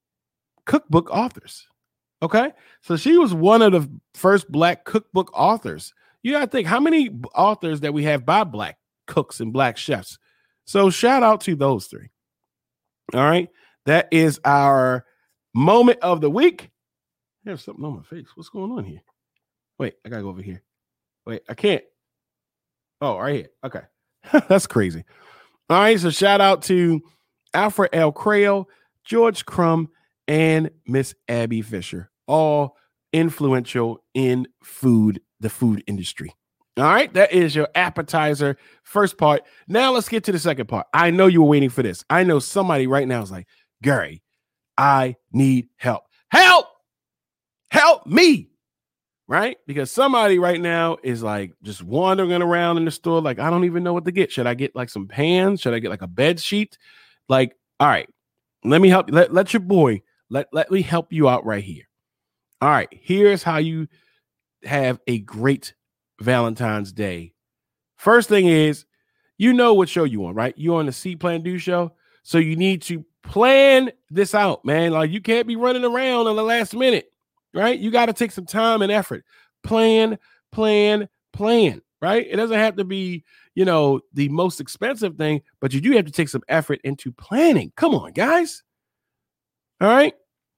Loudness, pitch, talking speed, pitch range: -19 LUFS, 170 Hz, 175 wpm, 135-210 Hz